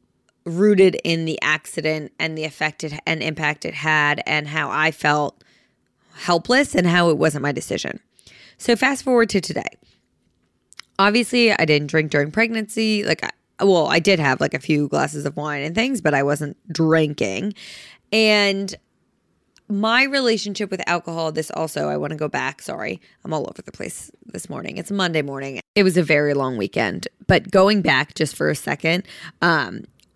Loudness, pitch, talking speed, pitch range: -20 LUFS, 160 Hz, 175 wpm, 150-200 Hz